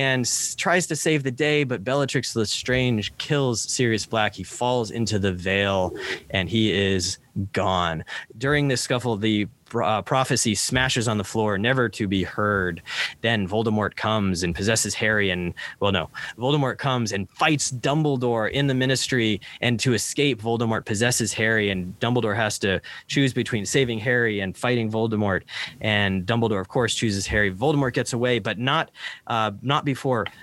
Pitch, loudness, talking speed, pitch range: 115 Hz, -23 LUFS, 165 wpm, 105-130 Hz